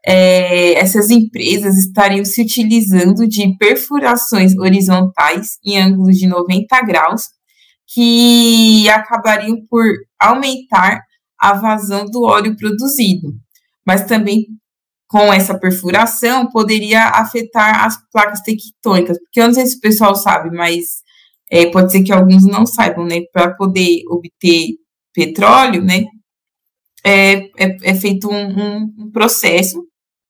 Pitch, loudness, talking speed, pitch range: 205 Hz, -11 LUFS, 125 wpm, 185-230 Hz